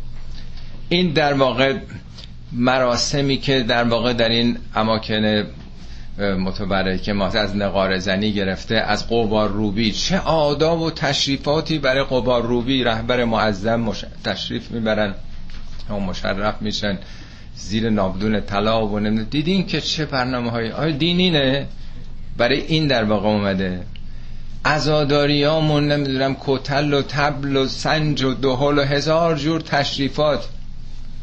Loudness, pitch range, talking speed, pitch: -19 LUFS, 105-145 Hz, 125 wpm, 120 Hz